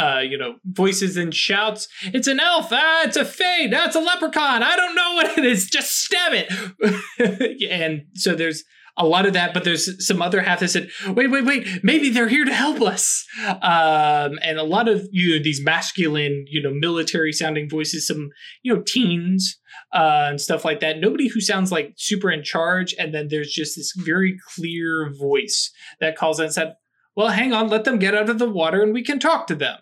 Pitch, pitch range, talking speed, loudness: 190 Hz, 160-235 Hz, 215 wpm, -19 LUFS